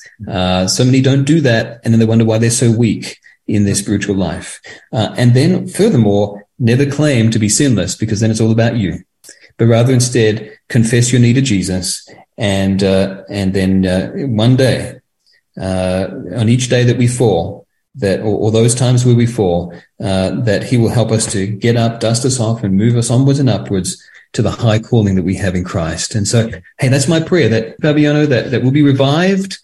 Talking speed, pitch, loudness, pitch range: 210 wpm, 115 Hz, -13 LUFS, 100-125 Hz